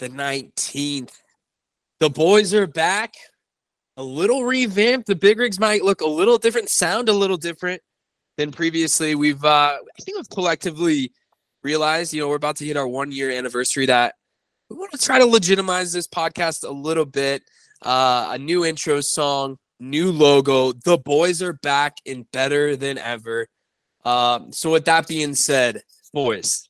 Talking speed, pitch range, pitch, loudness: 165 wpm, 140-180 Hz, 155 Hz, -19 LUFS